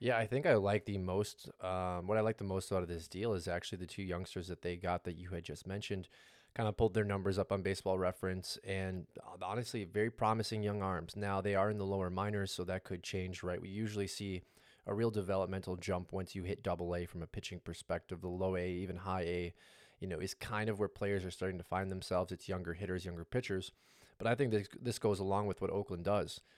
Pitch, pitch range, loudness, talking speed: 95 Hz, 90-105 Hz, -39 LUFS, 240 wpm